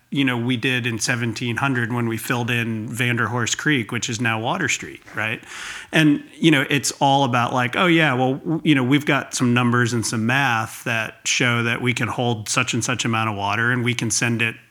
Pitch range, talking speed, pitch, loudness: 115-135 Hz, 225 wpm, 125 Hz, -20 LUFS